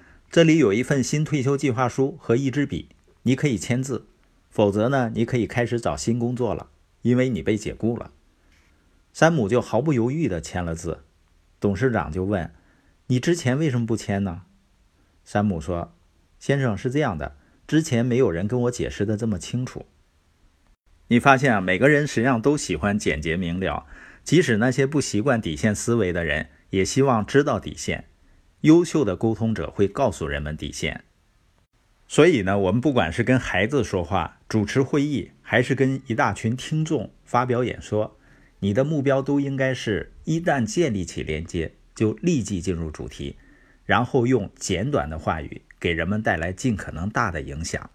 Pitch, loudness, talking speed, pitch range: 110 Hz, -23 LUFS, 260 characters per minute, 85-130 Hz